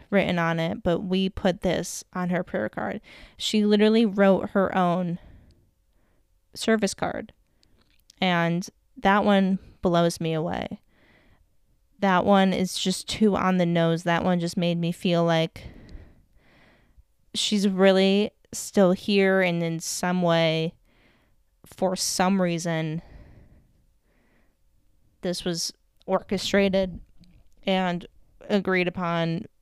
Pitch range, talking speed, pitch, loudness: 170-195 Hz, 115 wpm, 180 Hz, -24 LUFS